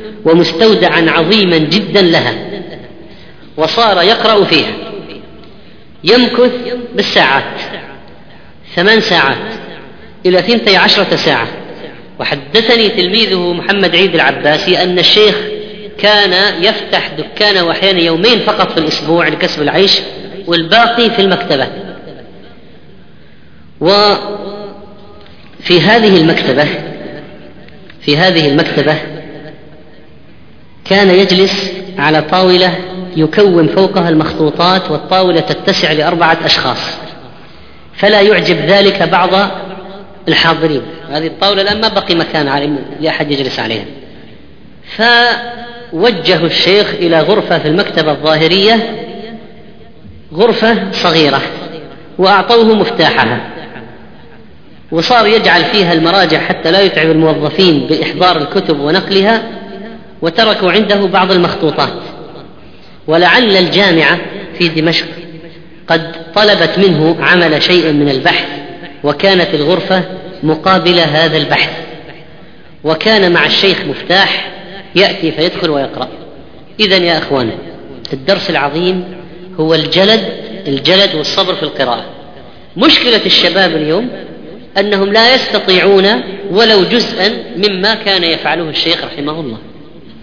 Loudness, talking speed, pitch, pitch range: -9 LUFS, 95 wpm, 180 Hz, 160-200 Hz